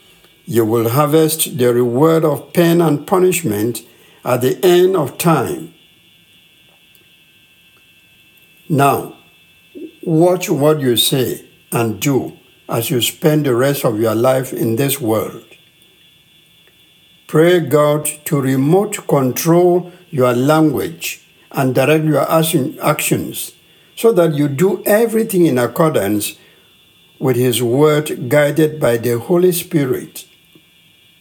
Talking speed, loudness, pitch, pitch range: 110 wpm, -15 LUFS, 155 Hz, 130-175 Hz